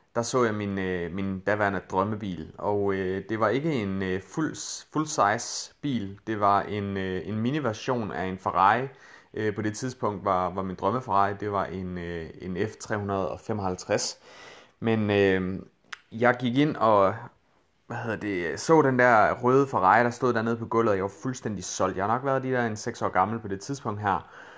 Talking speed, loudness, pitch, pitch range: 195 wpm, -27 LUFS, 105 Hz, 95-115 Hz